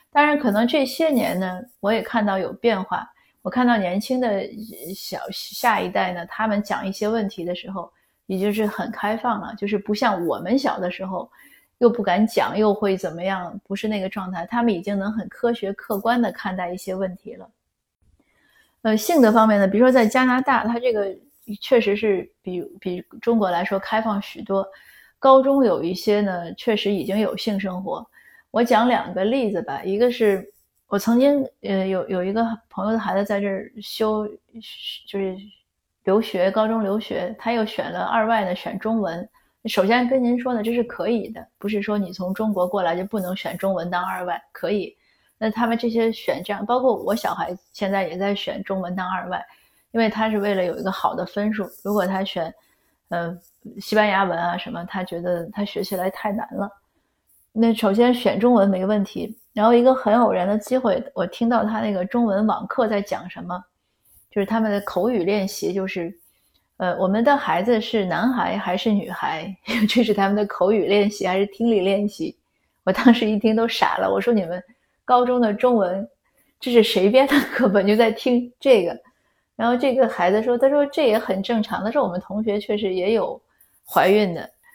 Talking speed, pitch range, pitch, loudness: 280 characters per minute, 190-235 Hz, 210 Hz, -21 LUFS